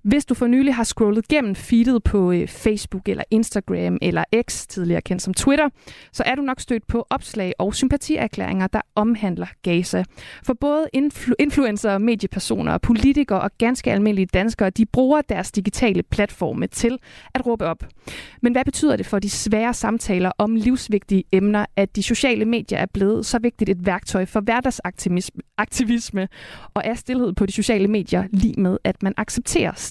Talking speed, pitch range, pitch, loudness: 170 wpm, 195-245 Hz, 220 Hz, -21 LUFS